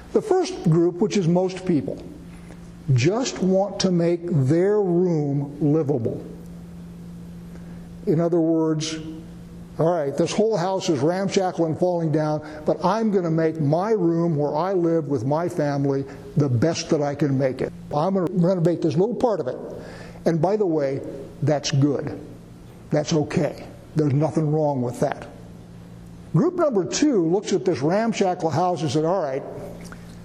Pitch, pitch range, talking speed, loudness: 165 Hz, 150-180 Hz, 160 wpm, -22 LUFS